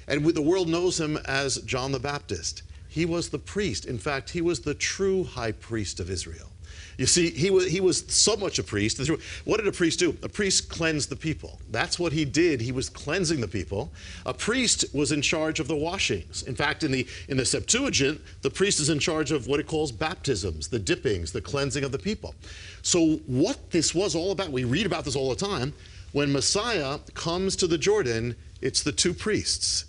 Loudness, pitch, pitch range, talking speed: -26 LUFS, 140 Hz, 110-165 Hz, 215 wpm